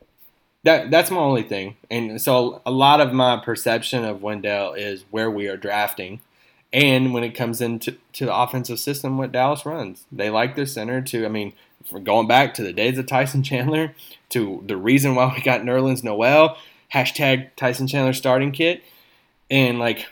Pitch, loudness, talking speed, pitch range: 125 Hz, -20 LUFS, 180 wpm, 115-135 Hz